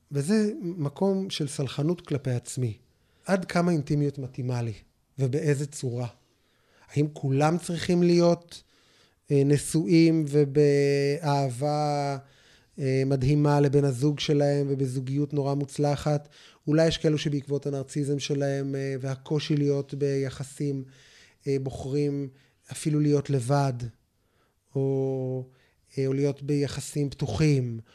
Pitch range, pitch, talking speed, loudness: 135-150 Hz, 145 Hz, 90 wpm, -26 LUFS